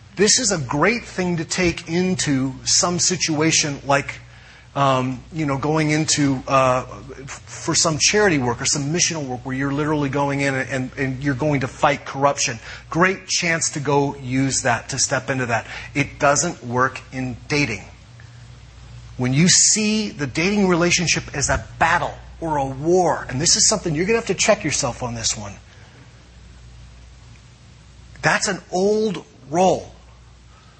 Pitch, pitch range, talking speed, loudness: 140 Hz, 125-165 Hz, 160 wpm, -19 LUFS